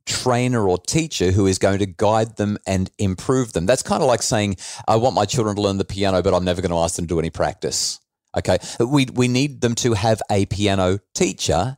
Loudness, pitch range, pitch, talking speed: -20 LUFS, 95-120 Hz, 105 Hz, 235 wpm